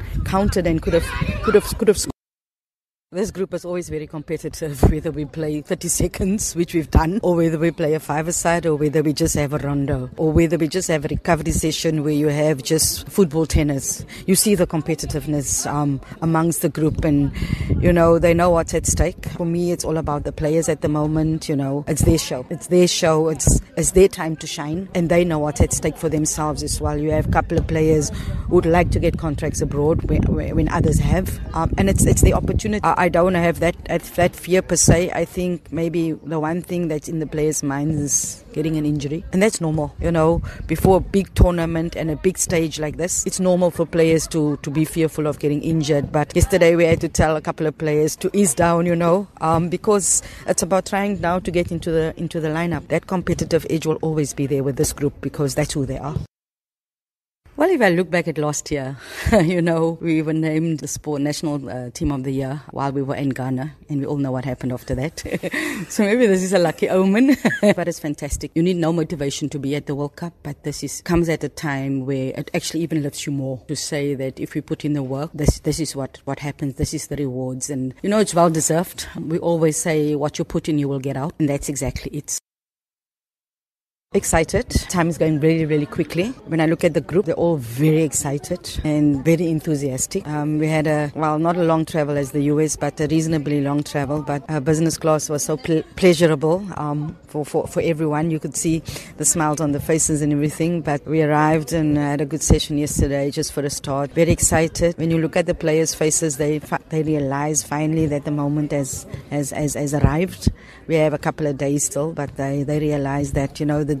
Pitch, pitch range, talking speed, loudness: 155 Hz, 145-170 Hz, 230 wpm, -20 LUFS